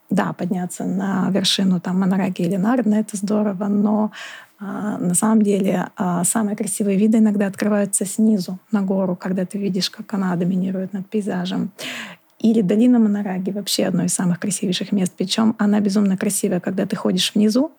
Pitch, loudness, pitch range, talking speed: 205 Hz, -20 LUFS, 190-215 Hz, 160 wpm